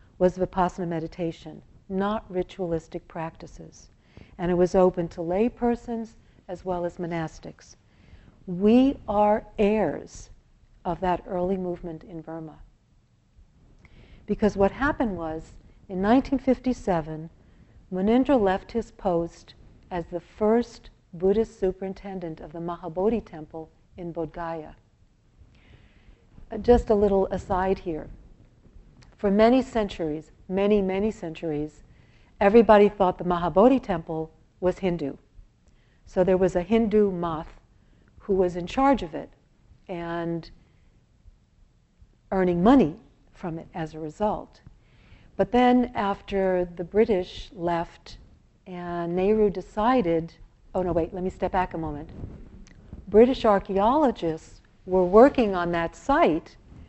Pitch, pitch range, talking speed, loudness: 185 Hz, 170-210 Hz, 115 wpm, -25 LUFS